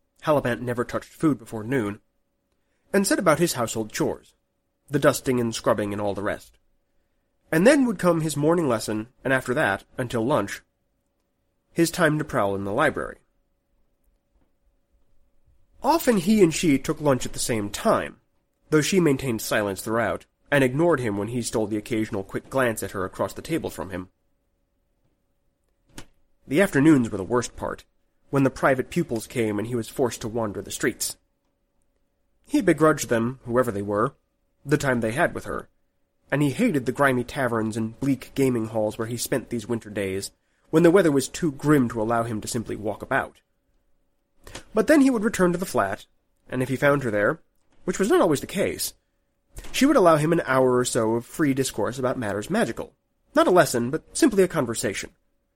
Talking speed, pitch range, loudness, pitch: 185 wpm, 110-150 Hz, -23 LUFS, 125 Hz